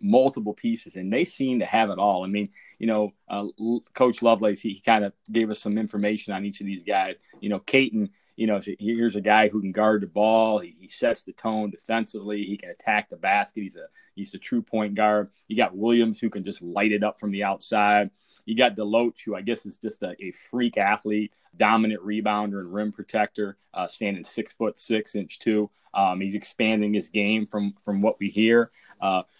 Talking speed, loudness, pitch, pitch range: 220 wpm, -25 LUFS, 105 Hz, 100-115 Hz